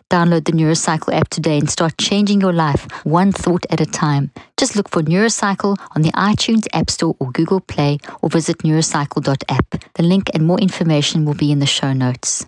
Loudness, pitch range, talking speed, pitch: -16 LUFS, 150-185 Hz, 195 wpm, 165 Hz